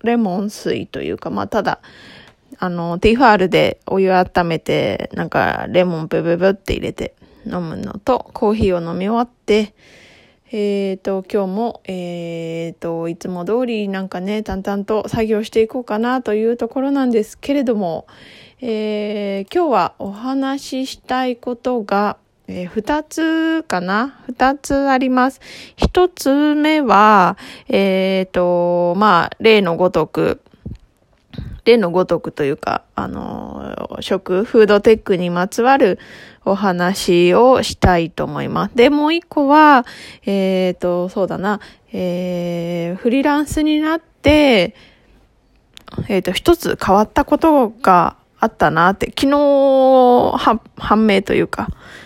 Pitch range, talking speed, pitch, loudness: 185-255 Hz, 260 characters per minute, 210 Hz, -16 LUFS